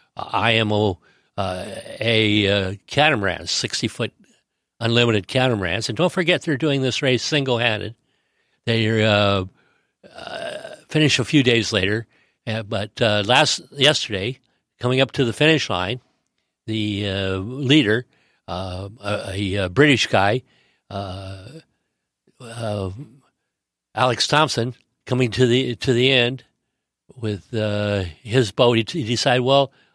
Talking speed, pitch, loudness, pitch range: 125 wpm, 115 Hz, -20 LUFS, 105-130 Hz